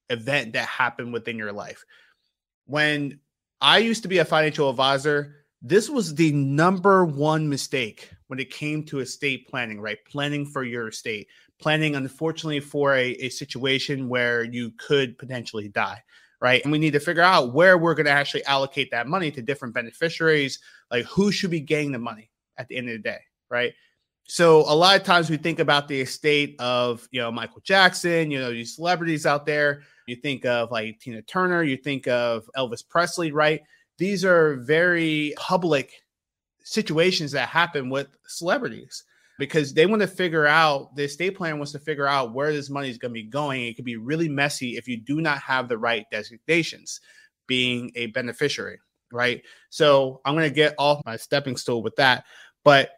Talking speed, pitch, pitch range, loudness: 185 wpm, 145 Hz, 125-160 Hz, -23 LUFS